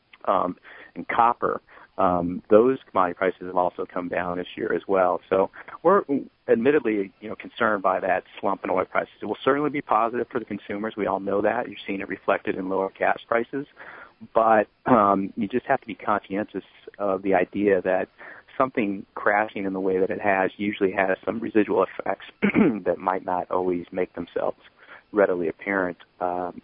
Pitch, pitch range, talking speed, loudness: 95 Hz, 90-105 Hz, 185 wpm, -24 LUFS